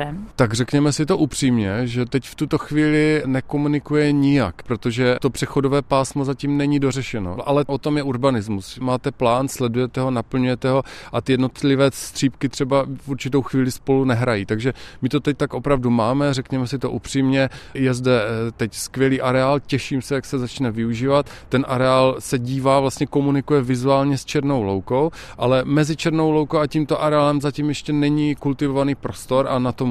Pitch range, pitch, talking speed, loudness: 125-145 Hz, 135 Hz, 175 wpm, -20 LUFS